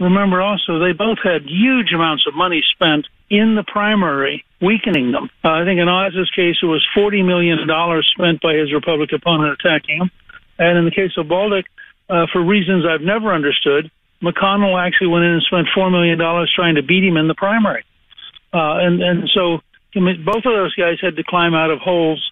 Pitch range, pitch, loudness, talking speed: 165-195 Hz, 180 Hz, -15 LUFS, 200 wpm